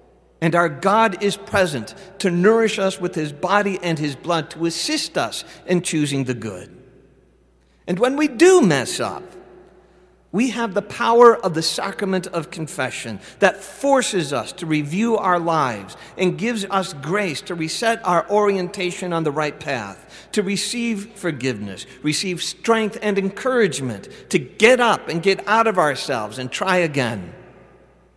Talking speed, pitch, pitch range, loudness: 155 wpm, 185 Hz, 155-205 Hz, -20 LUFS